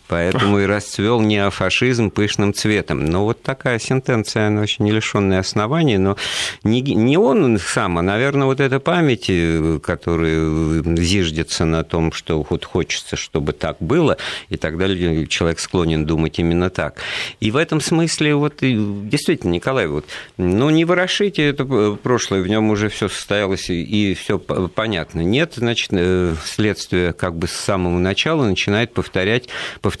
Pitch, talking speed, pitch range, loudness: 100 Hz, 150 wpm, 90-120 Hz, -18 LUFS